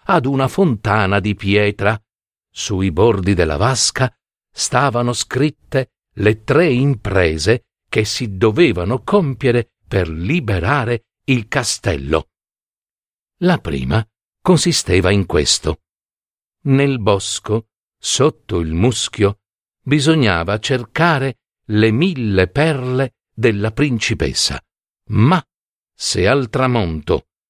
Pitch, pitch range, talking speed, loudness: 110 Hz, 100-130 Hz, 95 wpm, -17 LUFS